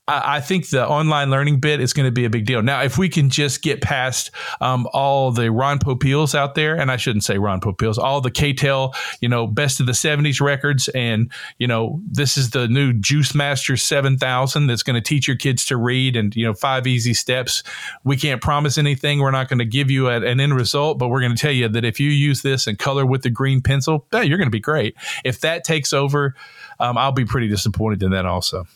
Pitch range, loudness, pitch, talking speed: 120-145 Hz, -18 LUFS, 135 Hz, 240 wpm